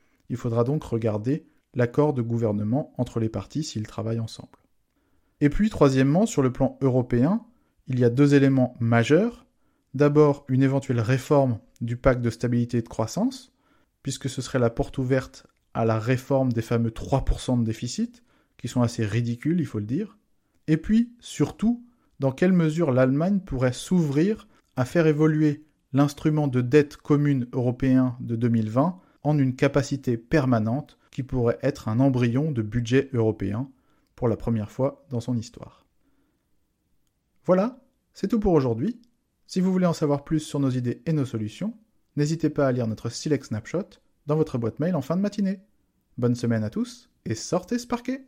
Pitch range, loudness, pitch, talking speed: 120-155 Hz, -25 LUFS, 135 Hz, 170 wpm